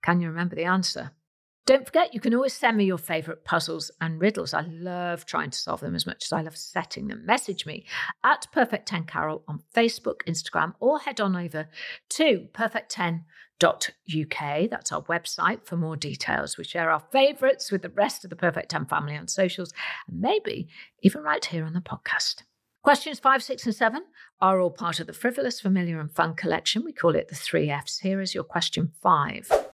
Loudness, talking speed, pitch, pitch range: -26 LUFS, 195 wpm, 185 Hz, 165-235 Hz